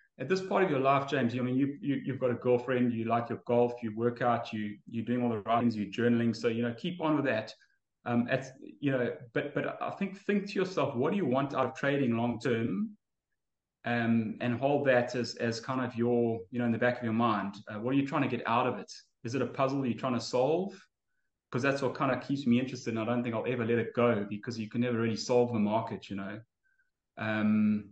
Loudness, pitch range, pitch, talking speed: -31 LUFS, 115-130 Hz, 120 Hz, 260 wpm